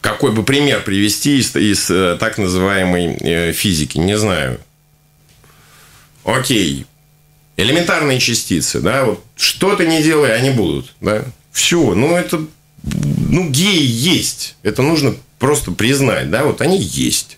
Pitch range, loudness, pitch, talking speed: 105-150 Hz, -15 LUFS, 135 Hz, 120 wpm